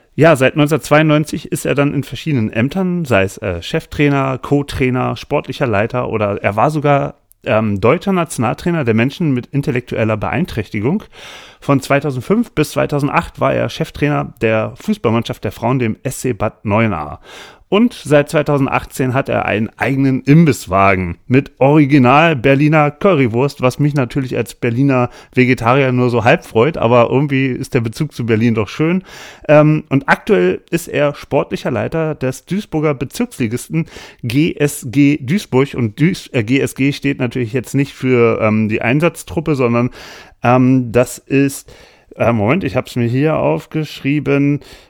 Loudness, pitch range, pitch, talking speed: -15 LUFS, 120-150 Hz, 135 Hz, 145 wpm